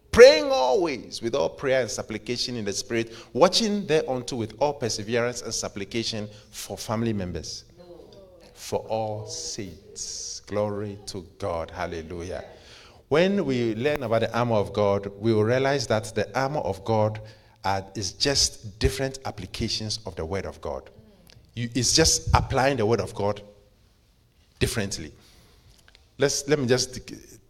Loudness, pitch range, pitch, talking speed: -25 LUFS, 100-125 Hz, 110 Hz, 145 wpm